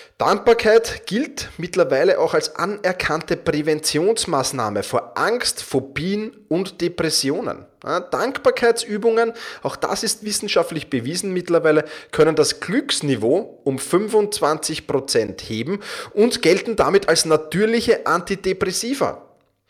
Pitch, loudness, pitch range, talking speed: 190 Hz, -20 LUFS, 155-225 Hz, 95 wpm